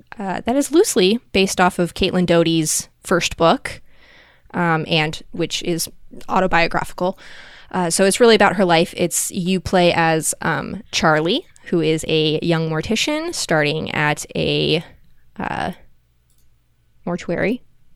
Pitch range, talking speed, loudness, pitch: 160-190 Hz, 130 wpm, -18 LUFS, 170 Hz